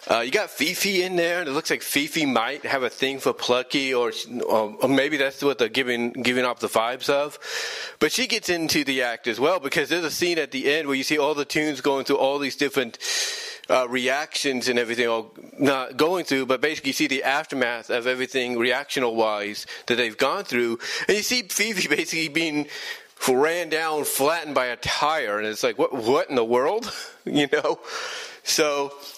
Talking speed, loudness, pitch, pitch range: 205 wpm, -23 LUFS, 140 Hz, 125-175 Hz